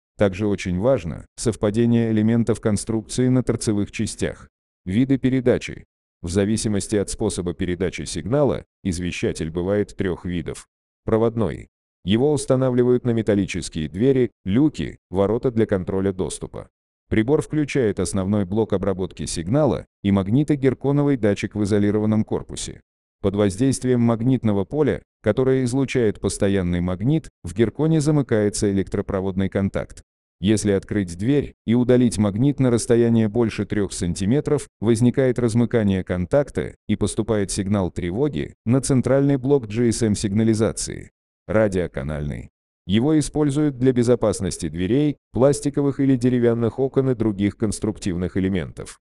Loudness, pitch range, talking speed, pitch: -21 LUFS, 95-125 Hz, 115 wpm, 110 Hz